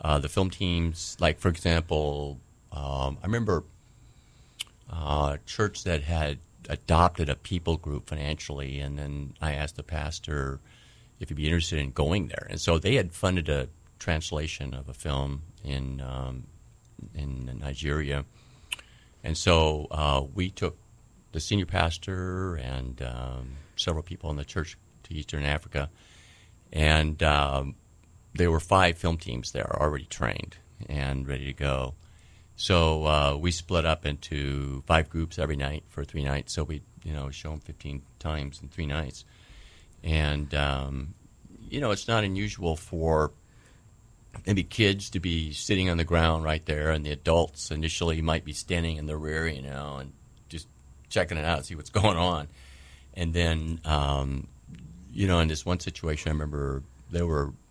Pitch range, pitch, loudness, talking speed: 70-90 Hz, 80 Hz, -29 LUFS, 160 wpm